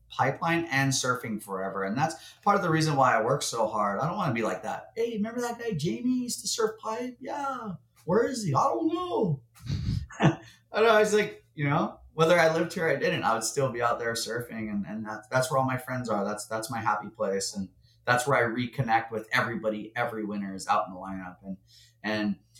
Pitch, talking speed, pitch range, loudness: 125 Hz, 230 wpm, 110-180 Hz, -28 LUFS